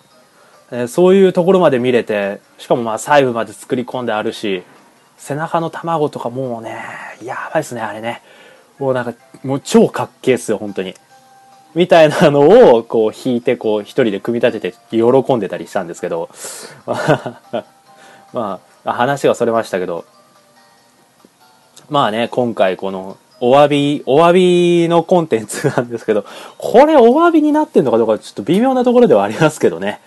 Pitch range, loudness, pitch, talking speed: 115-170 Hz, -14 LUFS, 130 Hz, 335 characters per minute